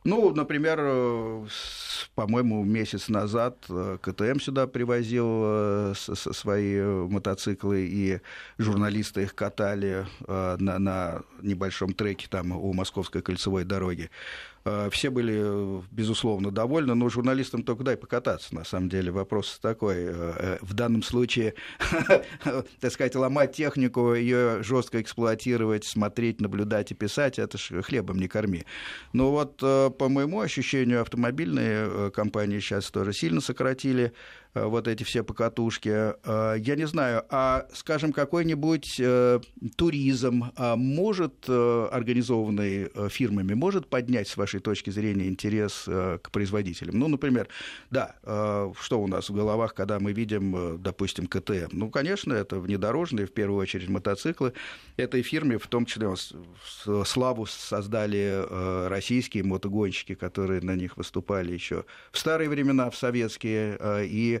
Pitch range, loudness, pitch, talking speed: 100-125 Hz, -28 LUFS, 105 Hz, 120 wpm